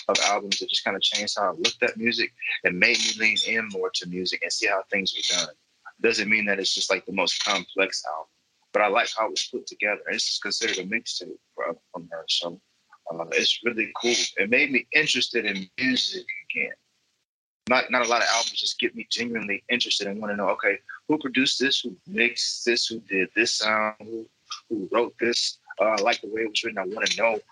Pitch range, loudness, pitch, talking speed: 100-120 Hz, -24 LUFS, 115 Hz, 225 wpm